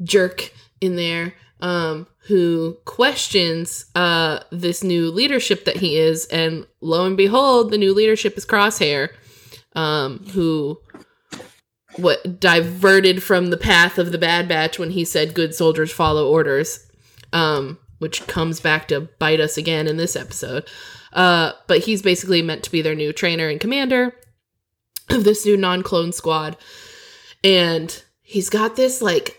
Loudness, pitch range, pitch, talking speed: -18 LUFS, 160-195 Hz, 170 Hz, 150 wpm